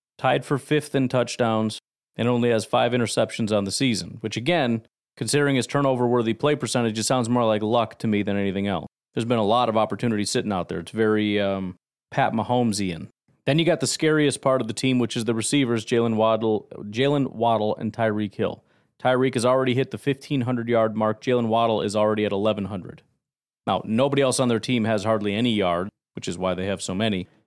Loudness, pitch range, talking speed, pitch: -23 LUFS, 105-130 Hz, 205 wpm, 115 Hz